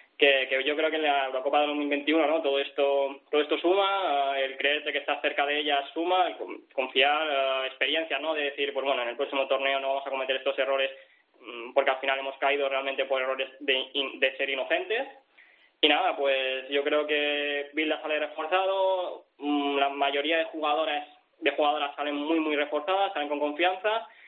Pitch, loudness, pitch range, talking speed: 145 Hz, -27 LUFS, 135-150 Hz, 190 wpm